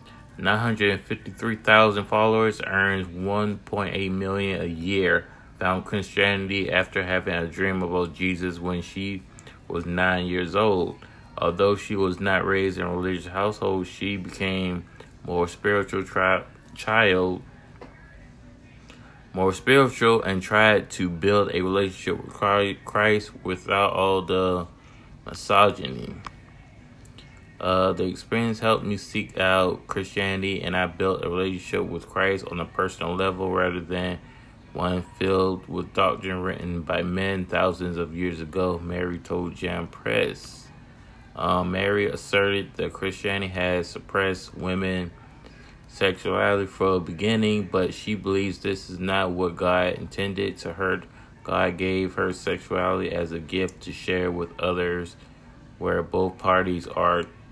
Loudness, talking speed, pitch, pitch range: -24 LUFS, 130 wpm, 95 Hz, 90-100 Hz